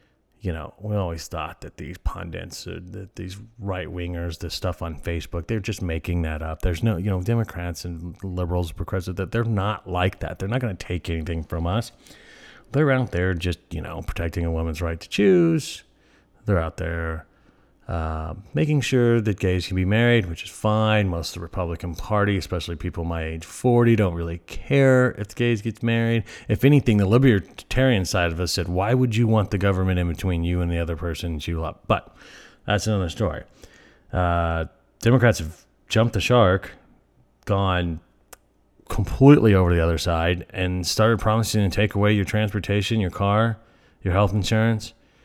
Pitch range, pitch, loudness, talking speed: 85-110 Hz, 95 Hz, -23 LUFS, 180 wpm